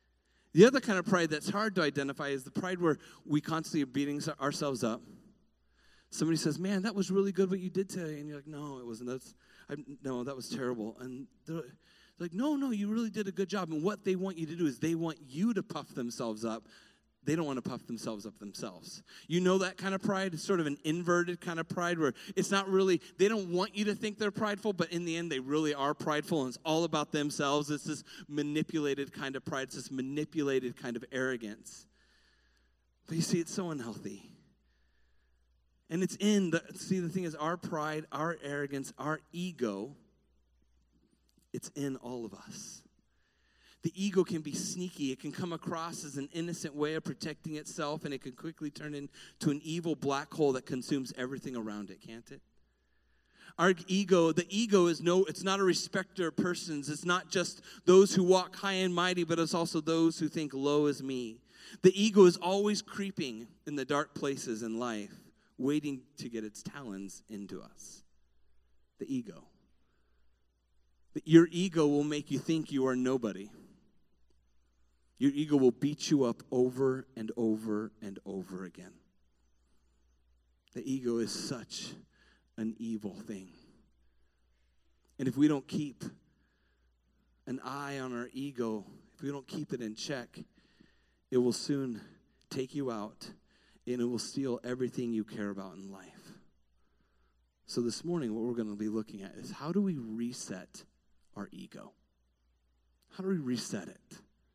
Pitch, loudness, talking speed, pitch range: 145 Hz, -33 LUFS, 185 wpm, 115-175 Hz